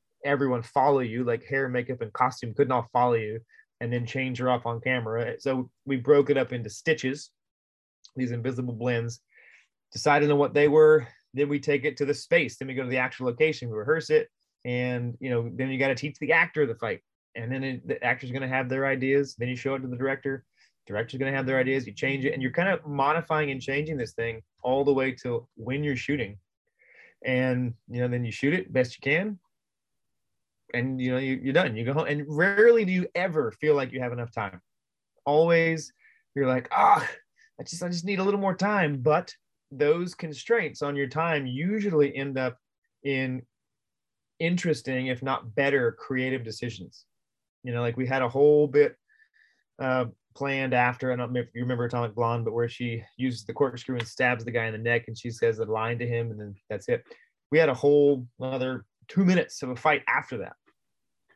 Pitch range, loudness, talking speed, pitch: 120-145 Hz, -26 LUFS, 215 wpm, 130 Hz